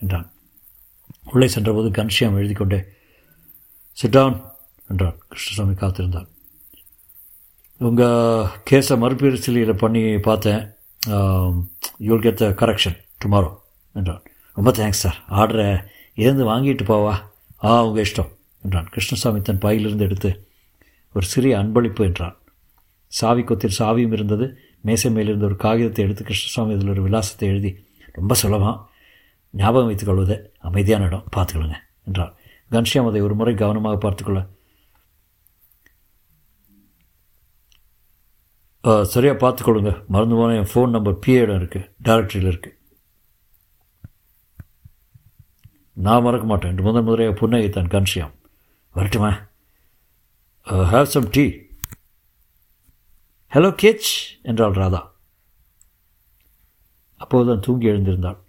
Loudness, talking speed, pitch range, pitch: -19 LUFS, 100 wpm, 95-115 Hz, 100 Hz